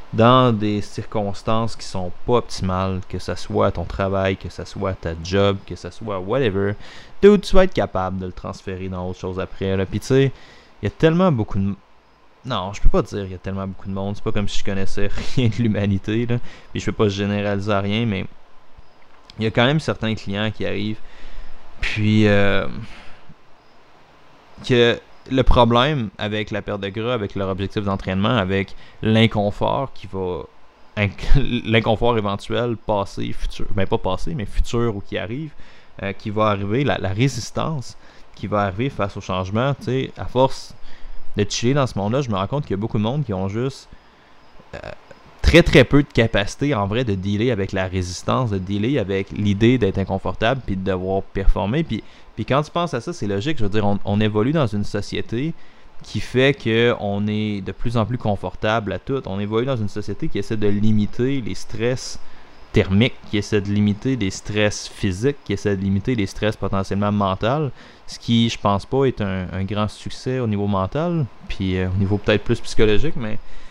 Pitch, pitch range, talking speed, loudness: 105 Hz, 95-120 Hz, 200 wpm, -21 LUFS